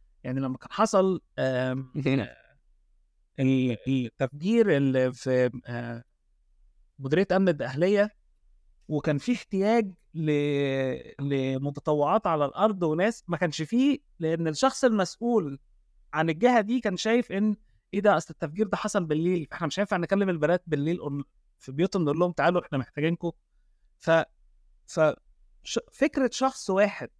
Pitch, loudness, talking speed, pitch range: 160 Hz, -27 LUFS, 120 wpm, 135-200 Hz